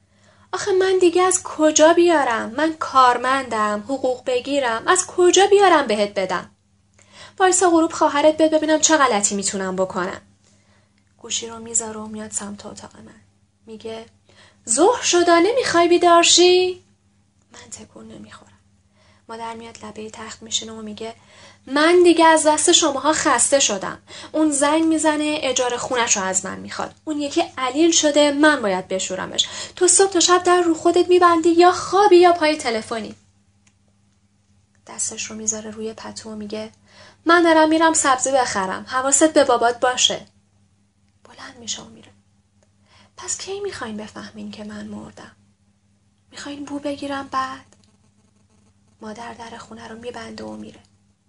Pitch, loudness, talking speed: 230 Hz, -17 LUFS, 140 wpm